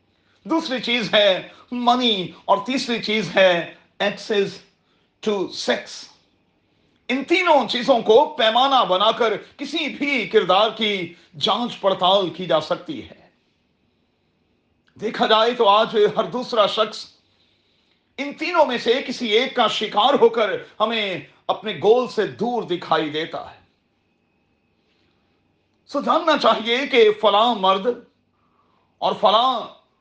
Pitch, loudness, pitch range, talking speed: 220 Hz, -19 LUFS, 195-245 Hz, 125 wpm